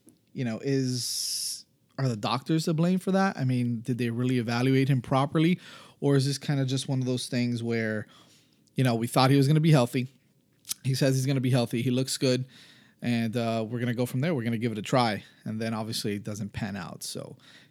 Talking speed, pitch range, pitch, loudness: 245 wpm, 120-135 Hz, 125 Hz, -27 LUFS